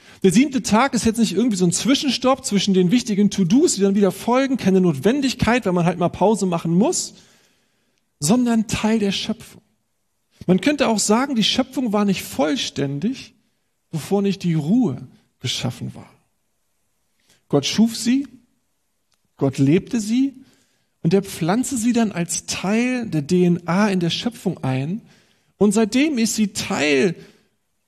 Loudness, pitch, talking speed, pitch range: -19 LUFS, 205 Hz, 150 wpm, 180-240 Hz